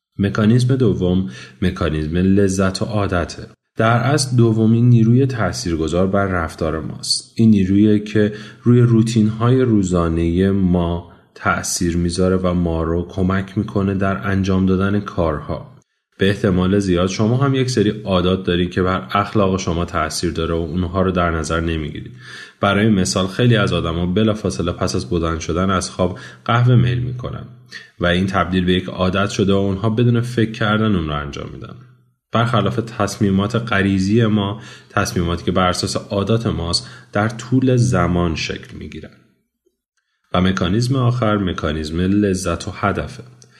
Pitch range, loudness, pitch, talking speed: 90-110 Hz, -18 LUFS, 100 Hz, 145 wpm